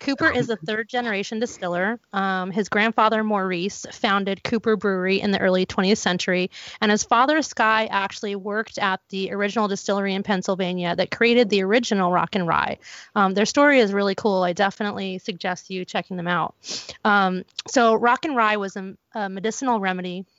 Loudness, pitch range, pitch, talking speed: -22 LUFS, 190-225 Hz, 200 Hz, 175 wpm